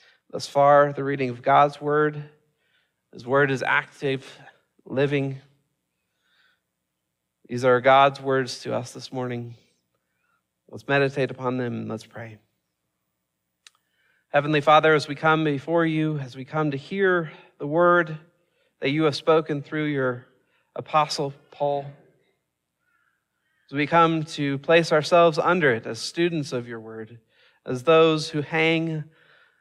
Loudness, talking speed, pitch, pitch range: -22 LUFS, 135 wpm, 145 Hz, 130-155 Hz